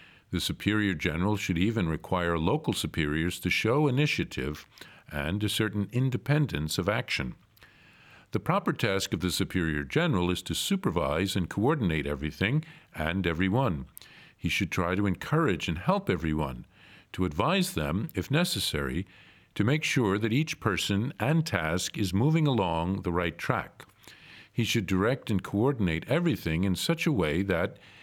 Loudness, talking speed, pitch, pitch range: -28 LUFS, 150 wpm, 95 Hz, 90-130 Hz